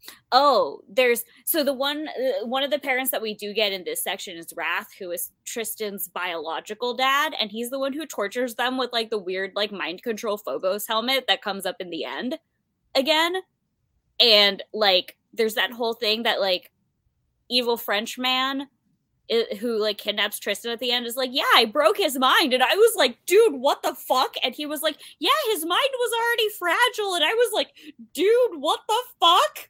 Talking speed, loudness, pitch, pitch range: 195 wpm, -23 LUFS, 255 Hz, 215-320 Hz